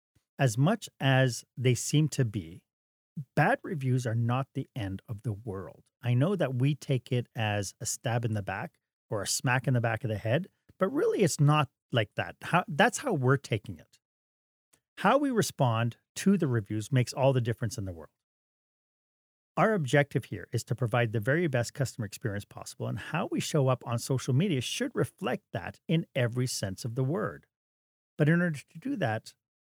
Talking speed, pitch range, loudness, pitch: 195 wpm, 115-150 Hz, -30 LUFS, 125 Hz